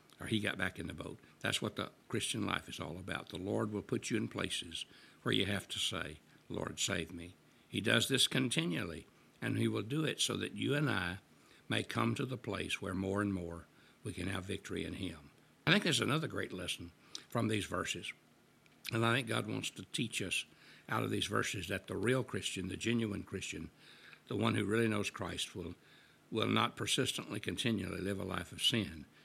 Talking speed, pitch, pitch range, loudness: 210 wpm, 100 Hz, 90-115 Hz, -37 LUFS